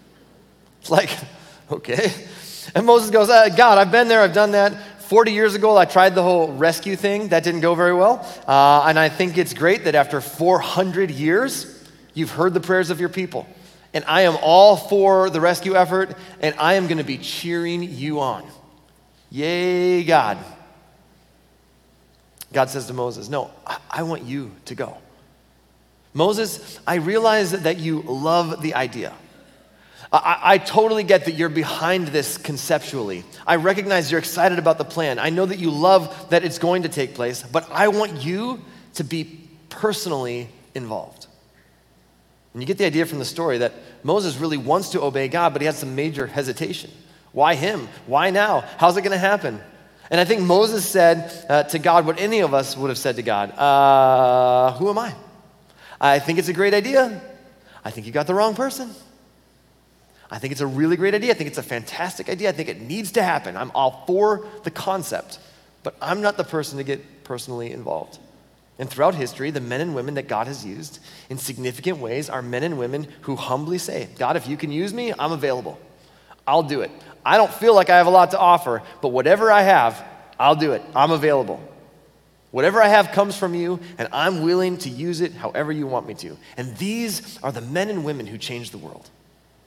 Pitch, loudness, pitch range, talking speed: 170 Hz, -19 LUFS, 140-190 Hz, 195 wpm